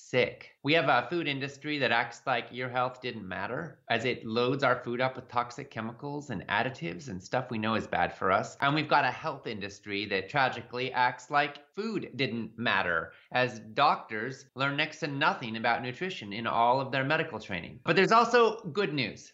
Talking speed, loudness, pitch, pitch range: 200 wpm, -30 LUFS, 125 Hz, 115-145 Hz